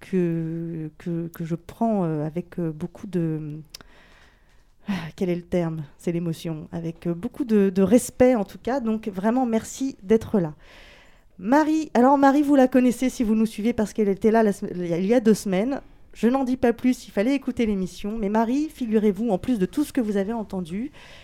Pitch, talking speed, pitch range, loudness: 210 Hz, 190 wpm, 175-245 Hz, -23 LUFS